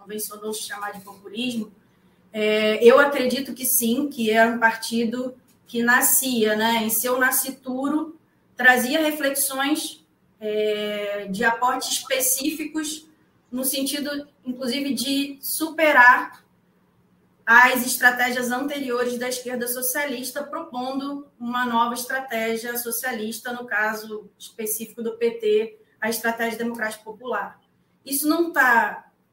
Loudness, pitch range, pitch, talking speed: -21 LUFS, 225-270 Hz, 250 Hz, 110 wpm